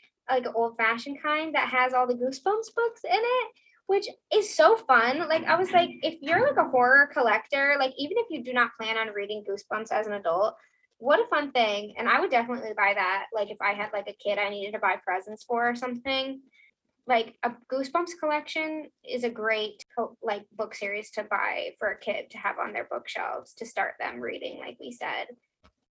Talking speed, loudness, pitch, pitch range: 215 wpm, -27 LUFS, 250 Hz, 215-310 Hz